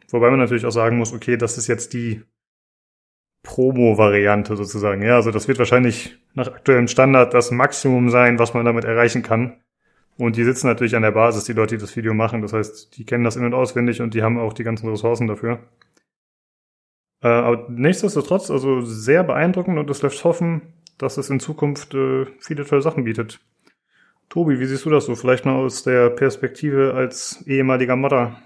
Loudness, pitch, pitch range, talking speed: -18 LUFS, 120 Hz, 115-135 Hz, 190 wpm